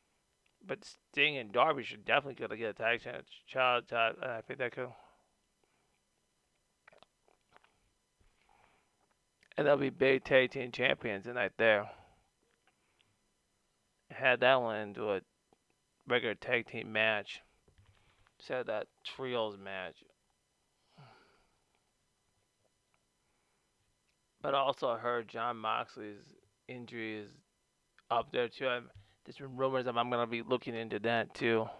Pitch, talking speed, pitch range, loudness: 115 Hz, 120 wpm, 105-125 Hz, -33 LUFS